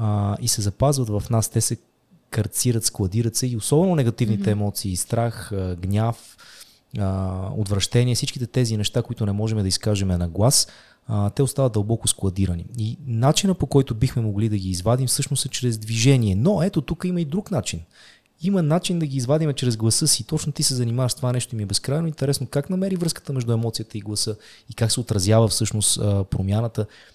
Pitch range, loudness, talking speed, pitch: 105-135 Hz, -22 LUFS, 185 wpm, 115 Hz